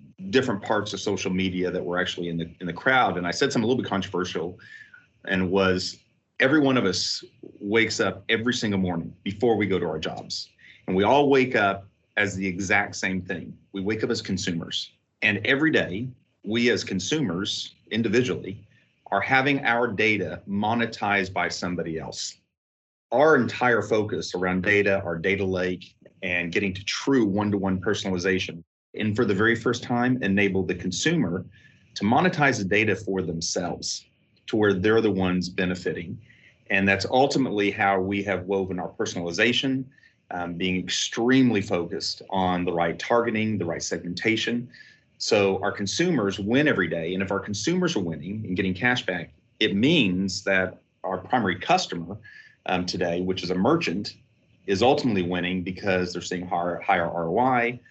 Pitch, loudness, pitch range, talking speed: 95 Hz, -24 LUFS, 90-110 Hz, 165 wpm